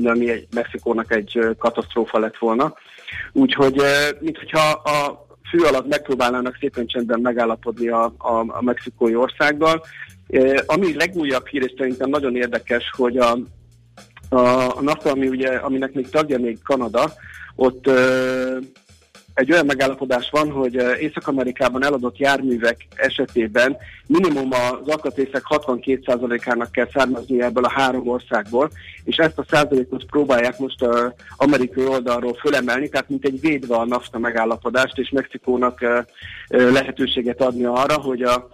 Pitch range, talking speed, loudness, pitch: 120-135 Hz, 130 wpm, -19 LUFS, 125 Hz